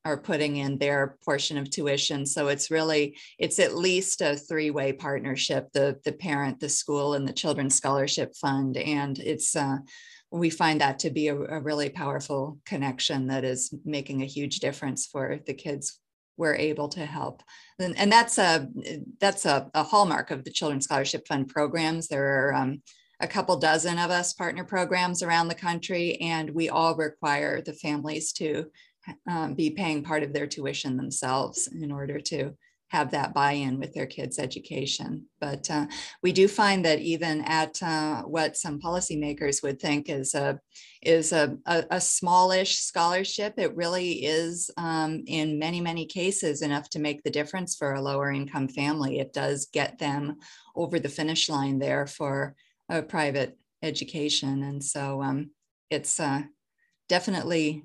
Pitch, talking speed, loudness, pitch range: 150 Hz, 170 wpm, -27 LUFS, 140-170 Hz